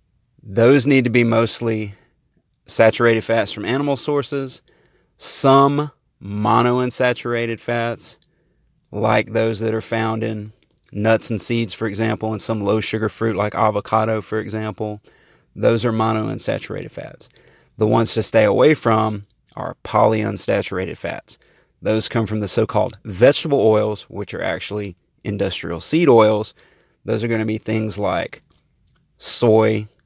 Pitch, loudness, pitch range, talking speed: 110 Hz, -19 LUFS, 105-115 Hz, 135 wpm